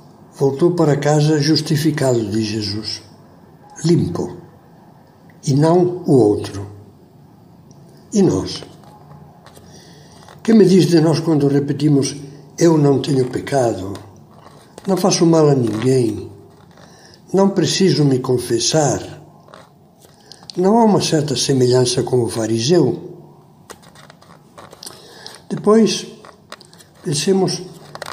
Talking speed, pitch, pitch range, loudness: 90 wpm, 155 Hz, 130-175 Hz, -16 LUFS